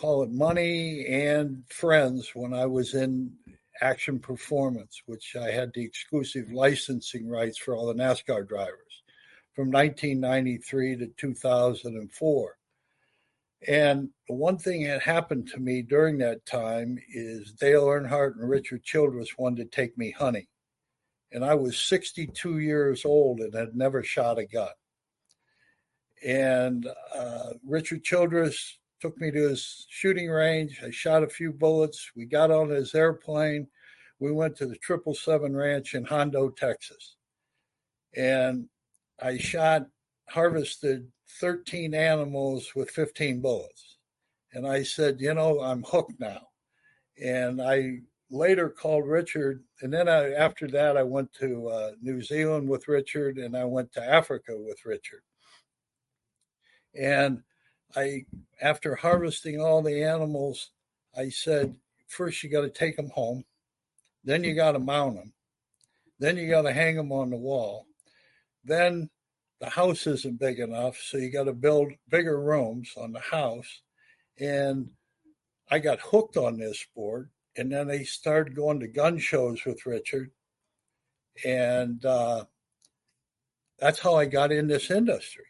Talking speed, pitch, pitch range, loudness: 145 wpm, 140 Hz, 130-155 Hz, -27 LUFS